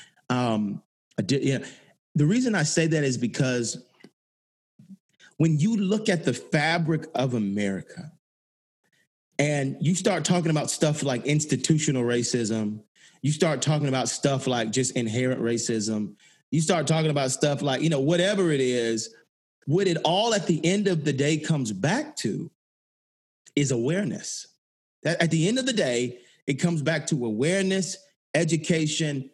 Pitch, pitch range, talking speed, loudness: 145 Hz, 125-165 Hz, 155 wpm, -25 LUFS